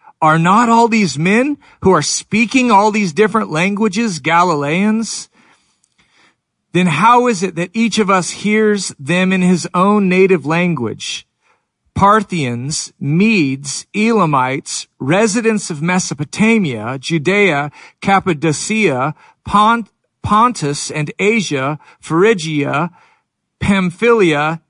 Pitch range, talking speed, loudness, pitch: 160-215 Hz, 100 wpm, -14 LUFS, 185 Hz